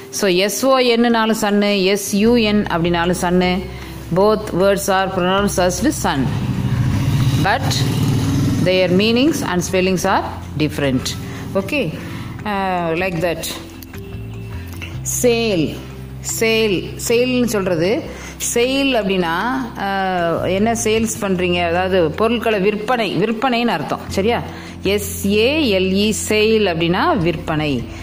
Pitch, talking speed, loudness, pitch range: 185 Hz, 80 wpm, -17 LUFS, 150-215 Hz